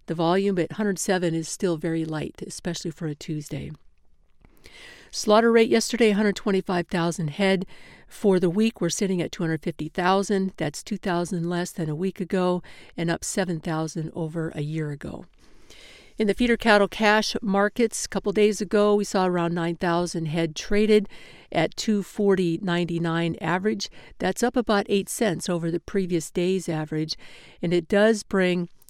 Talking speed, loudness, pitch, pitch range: 145 wpm, -24 LUFS, 180 Hz, 165-205 Hz